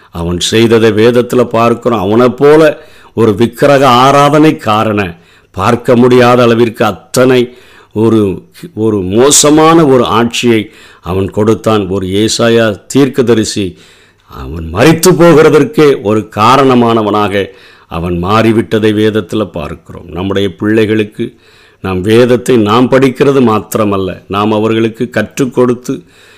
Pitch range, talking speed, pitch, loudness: 105-125 Hz, 100 wpm, 115 Hz, -8 LUFS